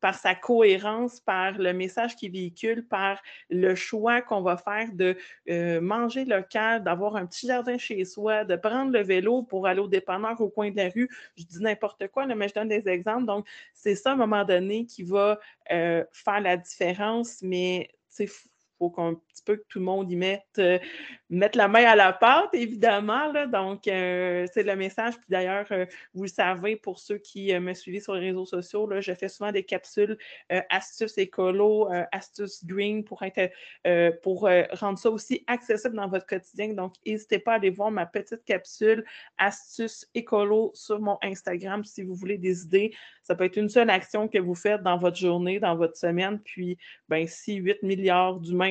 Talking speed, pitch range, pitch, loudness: 205 wpm, 185-215 Hz, 200 Hz, -26 LUFS